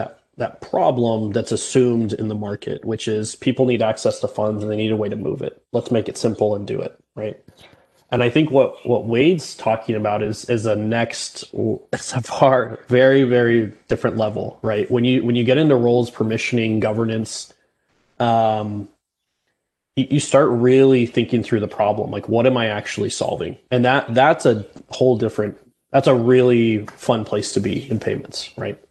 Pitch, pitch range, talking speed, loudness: 115 Hz, 110-125 Hz, 185 wpm, -19 LUFS